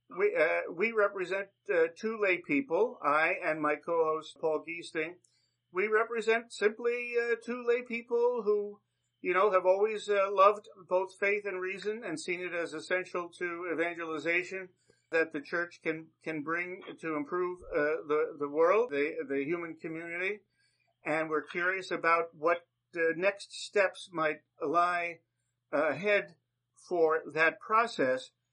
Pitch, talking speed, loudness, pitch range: 180 Hz, 145 wpm, -31 LUFS, 160-205 Hz